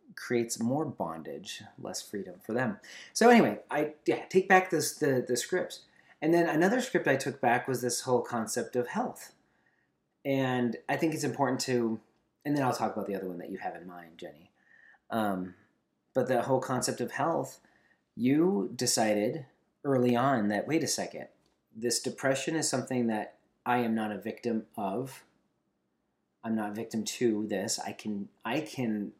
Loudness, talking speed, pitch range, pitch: -30 LUFS, 175 wpm, 110-145 Hz, 125 Hz